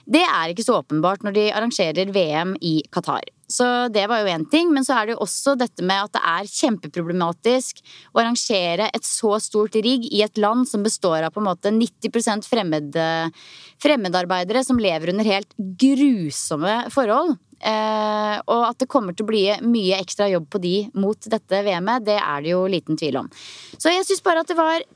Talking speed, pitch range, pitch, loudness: 195 wpm, 185-240 Hz, 210 Hz, -20 LUFS